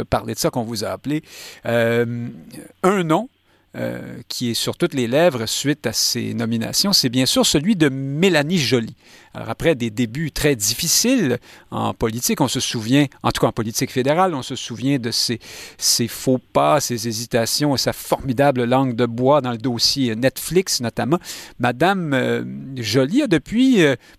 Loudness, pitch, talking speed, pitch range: -19 LUFS, 130 Hz, 180 wpm, 120-150 Hz